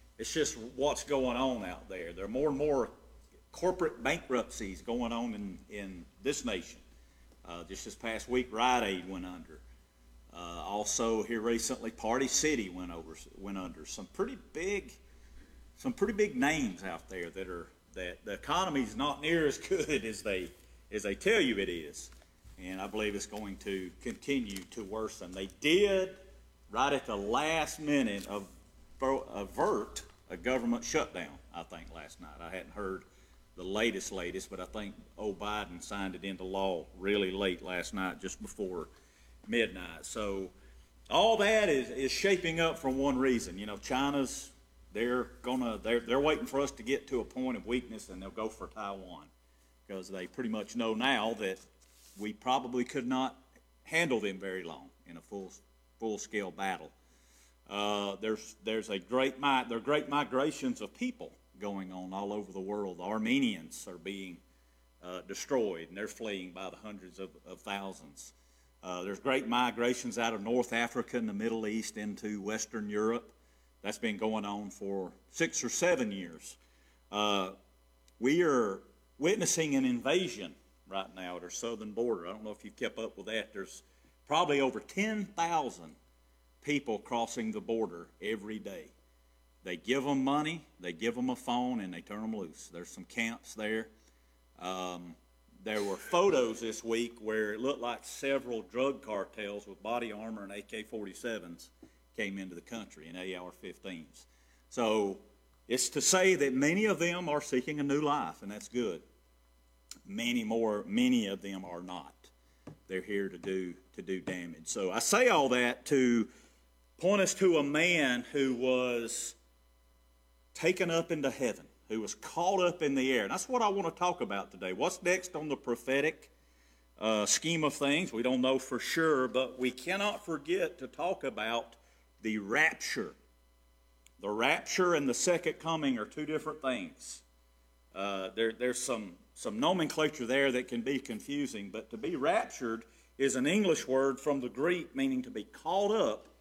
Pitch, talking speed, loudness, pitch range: 110 Hz, 170 wpm, -33 LUFS, 90-135 Hz